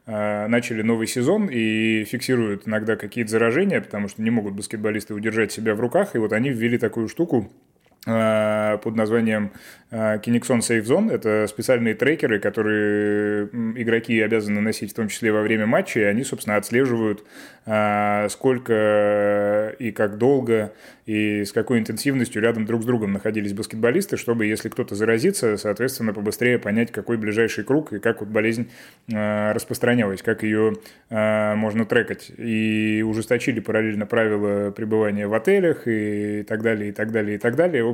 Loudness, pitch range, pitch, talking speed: -22 LUFS, 105-115 Hz, 110 Hz, 150 wpm